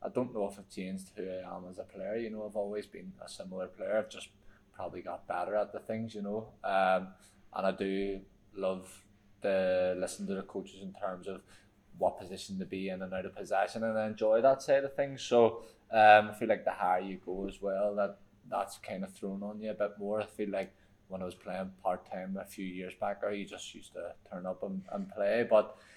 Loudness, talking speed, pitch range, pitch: -34 LUFS, 240 wpm, 95-110 Hz, 100 Hz